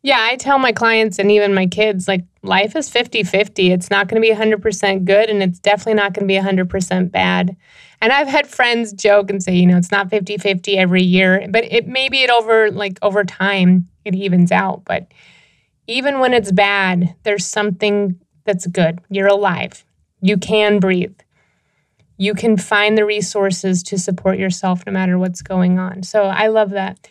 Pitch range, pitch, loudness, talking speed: 185-215 Hz, 200 Hz, -15 LUFS, 190 wpm